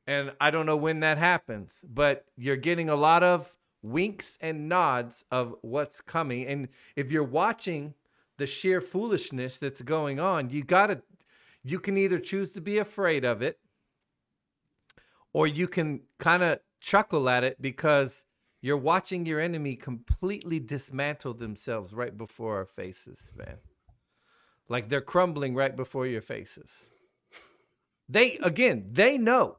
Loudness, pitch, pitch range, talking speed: -28 LUFS, 150 Hz, 130-175 Hz, 145 wpm